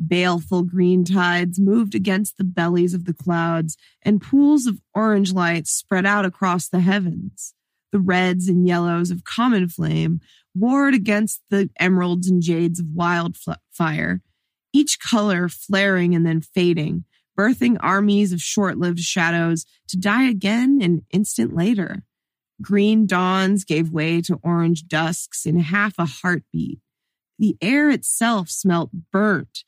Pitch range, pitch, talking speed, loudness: 170-205 Hz, 180 Hz, 140 wpm, -20 LUFS